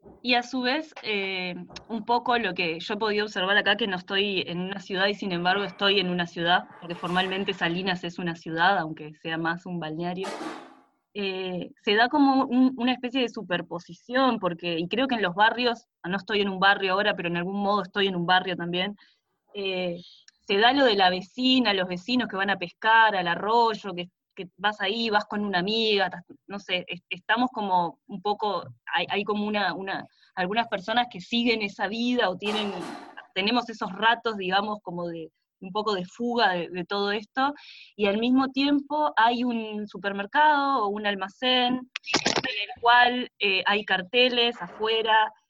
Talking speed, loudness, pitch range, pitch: 185 wpm, -25 LUFS, 185-235 Hz, 200 Hz